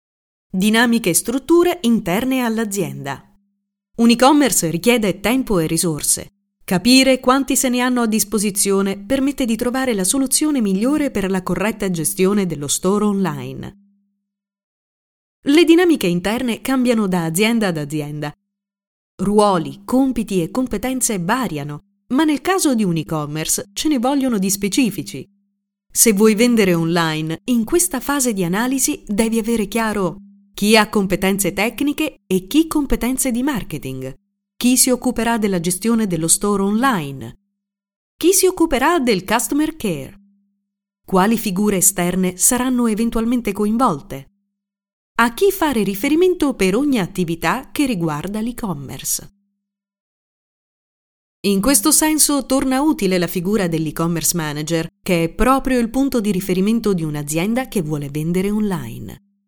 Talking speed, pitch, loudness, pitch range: 130 wpm, 205 Hz, -17 LUFS, 185-255 Hz